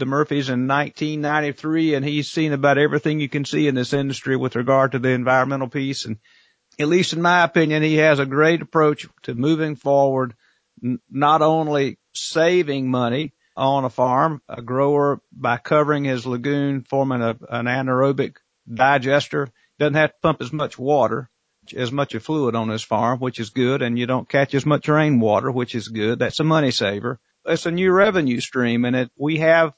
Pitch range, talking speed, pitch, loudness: 125-150 Hz, 190 wpm, 140 Hz, -20 LUFS